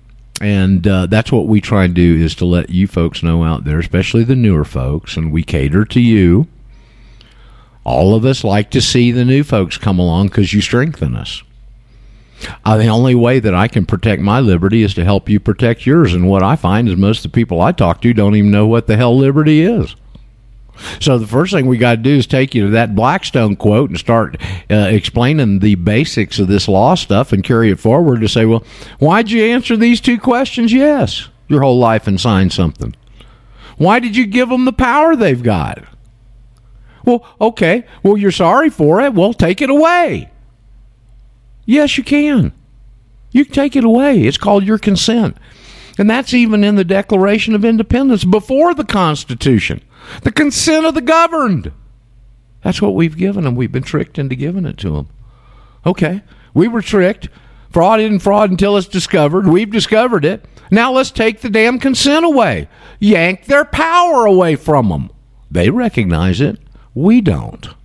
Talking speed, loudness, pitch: 190 wpm, -12 LUFS, 120 Hz